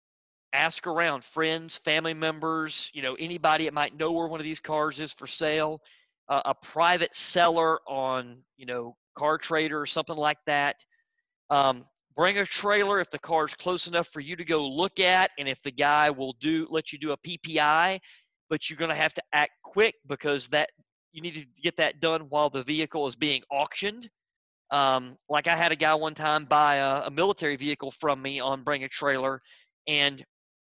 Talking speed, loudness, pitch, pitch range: 195 wpm, -27 LUFS, 155 Hz, 145-165 Hz